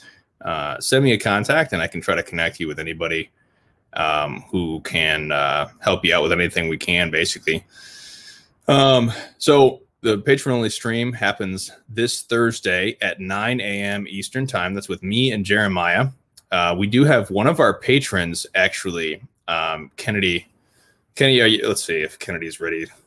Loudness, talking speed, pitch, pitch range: -20 LUFS, 160 wpm, 105 Hz, 90-125 Hz